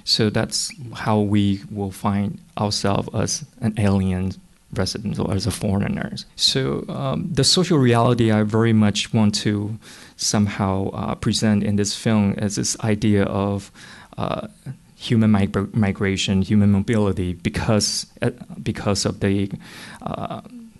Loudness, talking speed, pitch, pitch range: -21 LUFS, 135 wpm, 105 Hz, 100-110 Hz